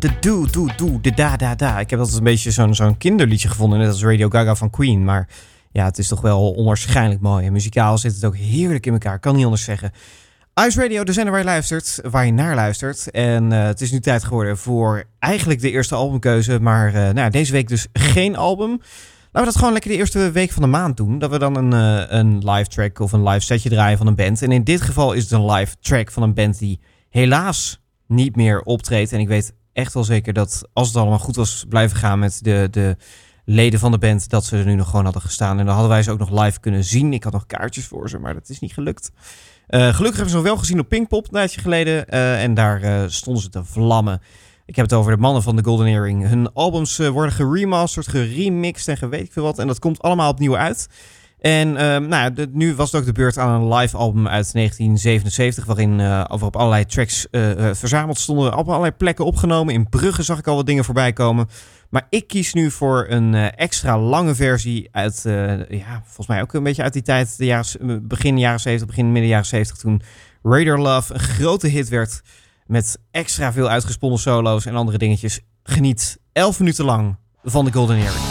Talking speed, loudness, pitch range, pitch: 235 wpm, -18 LUFS, 105-140 Hz, 115 Hz